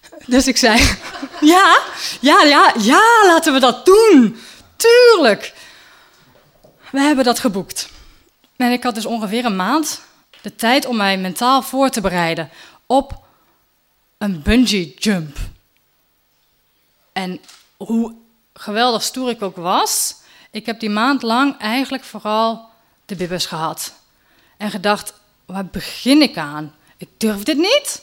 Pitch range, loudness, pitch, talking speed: 195-270 Hz, -15 LUFS, 230 Hz, 135 wpm